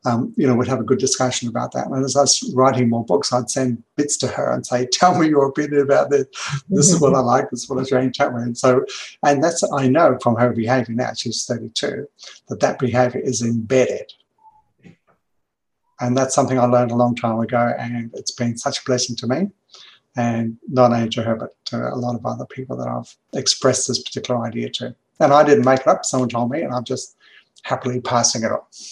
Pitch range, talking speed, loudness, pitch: 120-140 Hz, 235 wpm, -19 LUFS, 125 Hz